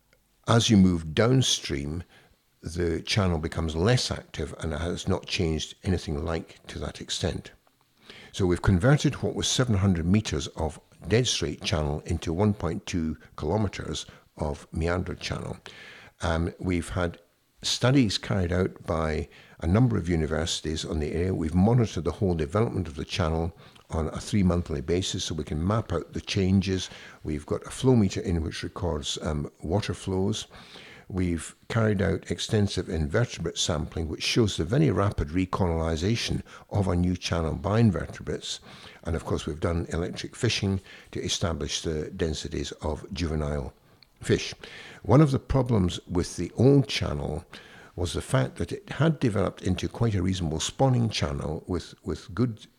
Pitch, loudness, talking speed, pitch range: 90 Hz, -27 LUFS, 155 wpm, 80-105 Hz